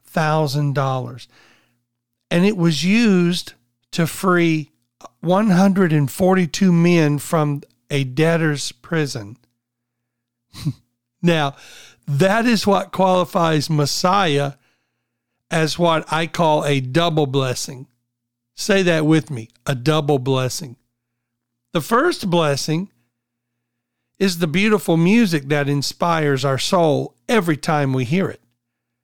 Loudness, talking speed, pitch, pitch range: -18 LUFS, 100 wpm, 150 Hz, 125-170 Hz